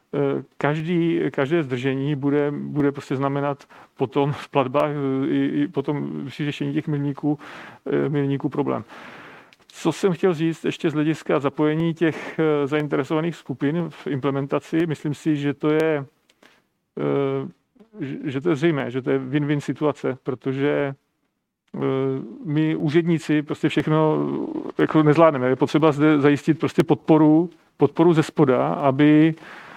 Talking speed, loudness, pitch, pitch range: 125 wpm, -22 LUFS, 150 Hz, 140-155 Hz